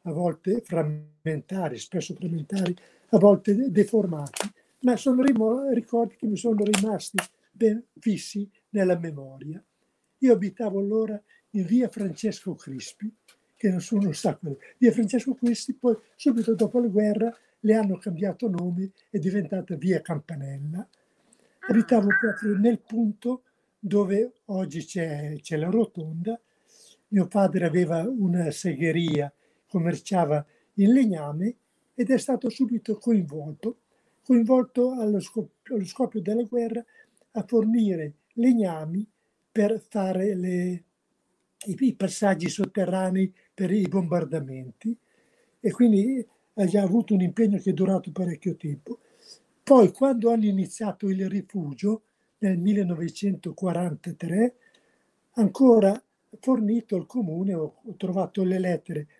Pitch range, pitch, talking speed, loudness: 180-230 Hz, 205 Hz, 120 wpm, -25 LUFS